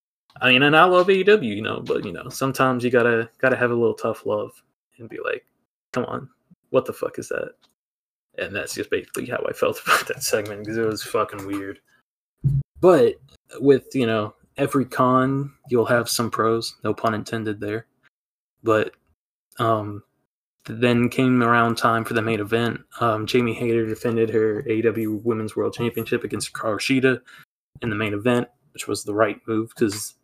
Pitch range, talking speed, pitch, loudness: 110-135 Hz, 180 wpm, 120 Hz, -22 LUFS